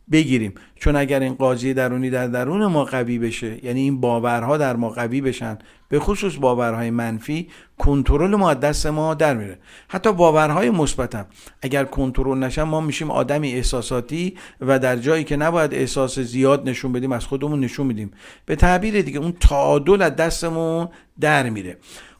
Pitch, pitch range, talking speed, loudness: 135 Hz, 125-155 Hz, 165 wpm, -20 LUFS